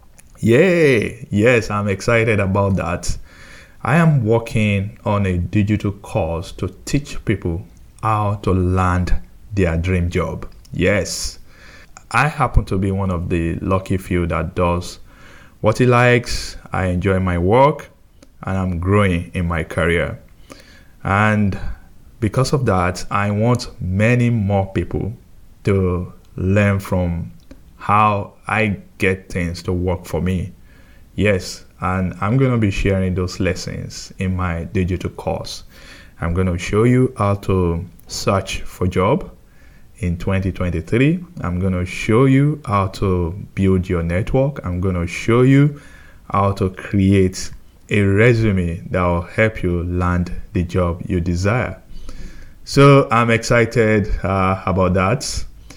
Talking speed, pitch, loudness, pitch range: 135 wpm, 95 Hz, -18 LUFS, 90-110 Hz